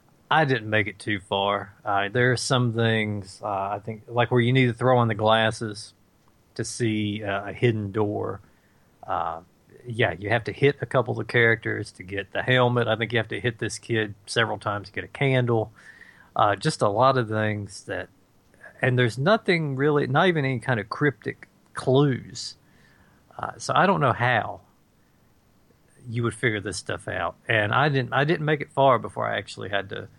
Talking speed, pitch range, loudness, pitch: 200 wpm, 105-130 Hz, -24 LUFS, 115 Hz